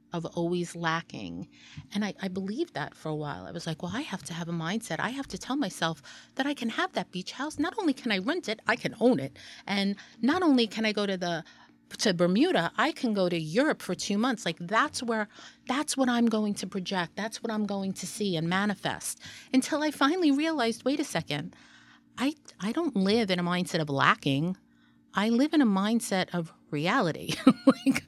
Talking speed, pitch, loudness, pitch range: 220 wpm, 210 Hz, -29 LUFS, 175-260 Hz